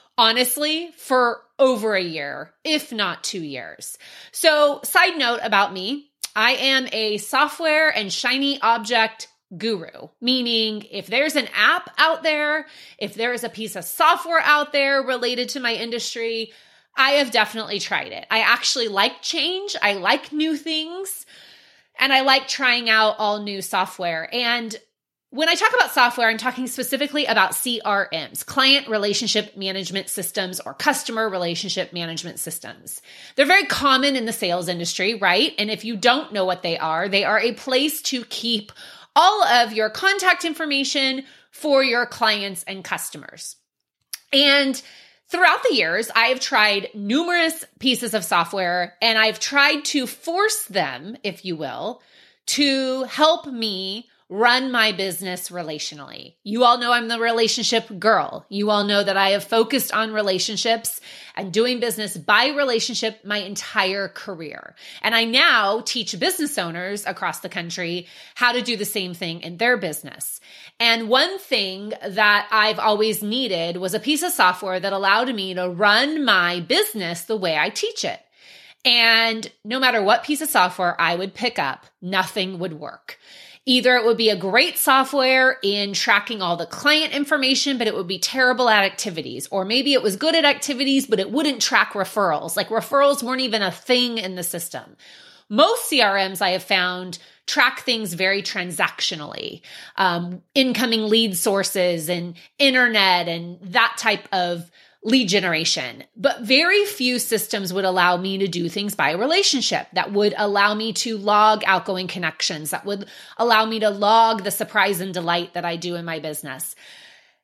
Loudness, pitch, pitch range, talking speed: -20 LUFS, 225 Hz, 195-260 Hz, 165 wpm